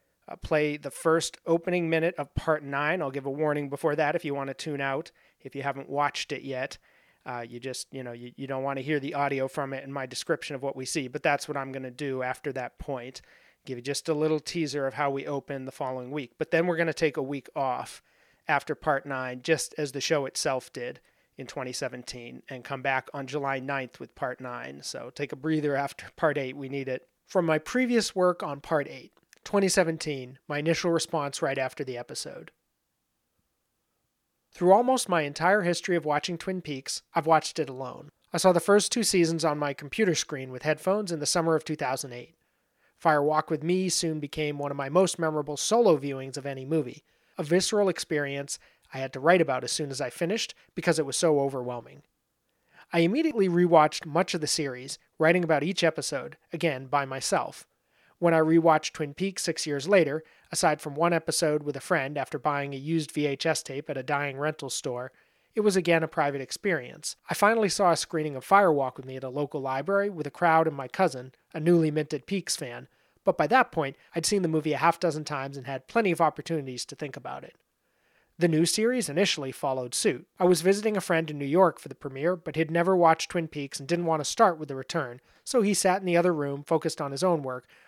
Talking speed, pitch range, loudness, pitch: 220 wpm, 135-170 Hz, -27 LUFS, 150 Hz